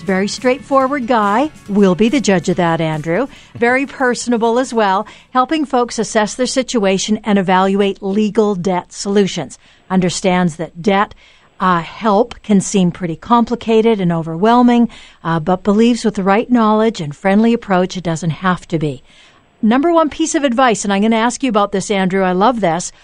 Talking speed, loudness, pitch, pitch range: 175 wpm, -15 LUFS, 205 Hz, 185-240 Hz